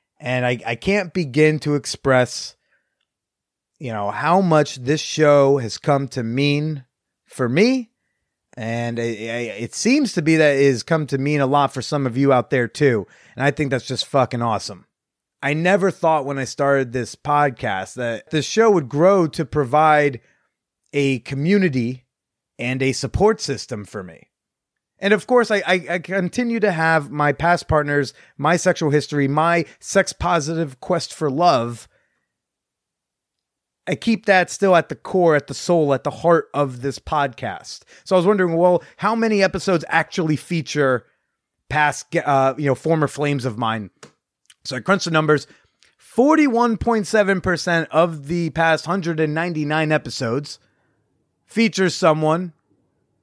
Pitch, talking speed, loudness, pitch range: 150 Hz, 155 wpm, -19 LUFS, 135-175 Hz